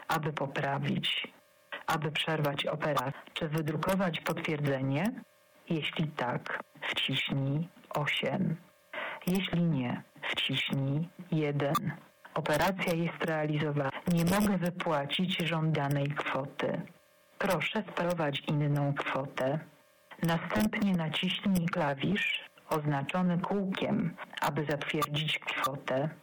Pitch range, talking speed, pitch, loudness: 150-185 Hz, 80 wpm, 160 Hz, -32 LUFS